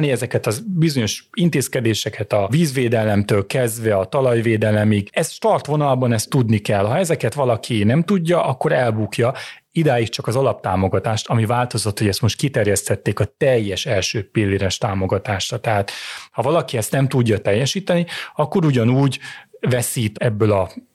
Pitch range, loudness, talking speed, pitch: 110-145 Hz, -19 LUFS, 140 wpm, 120 Hz